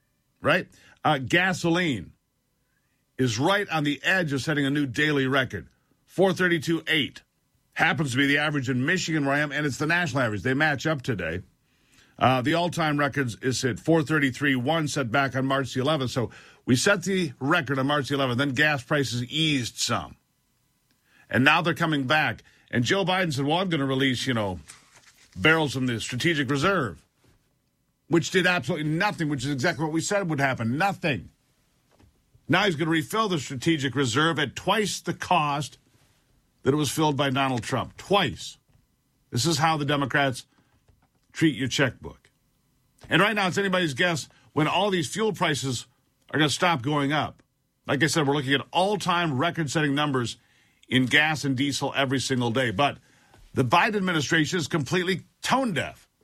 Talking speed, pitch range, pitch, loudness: 180 wpm, 135-165 Hz, 145 Hz, -24 LUFS